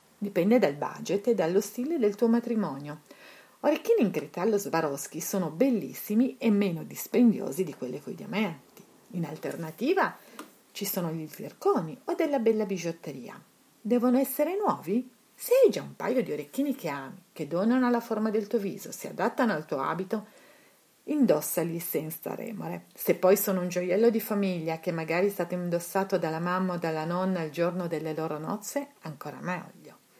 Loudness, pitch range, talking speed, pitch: -29 LUFS, 165-235 Hz, 165 wpm, 195 Hz